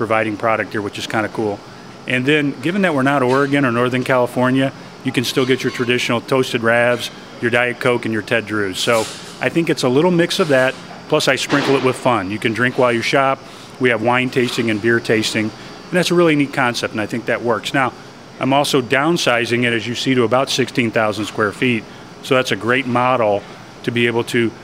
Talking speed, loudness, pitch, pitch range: 230 wpm, -17 LUFS, 125 Hz, 115-135 Hz